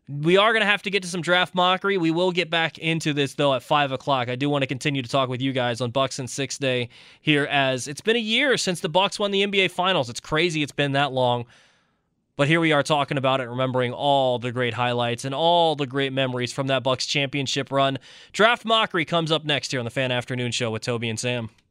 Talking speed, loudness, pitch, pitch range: 255 wpm, -22 LUFS, 140 Hz, 130-170 Hz